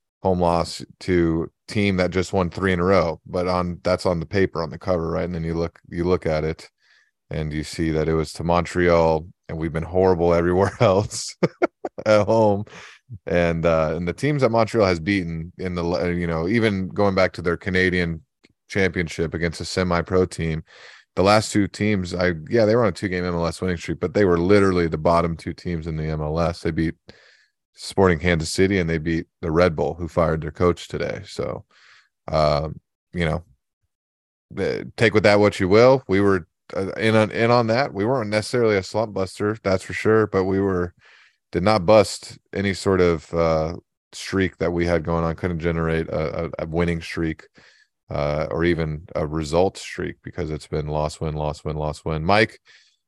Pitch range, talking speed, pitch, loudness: 80-95 Hz, 200 wpm, 85 Hz, -22 LUFS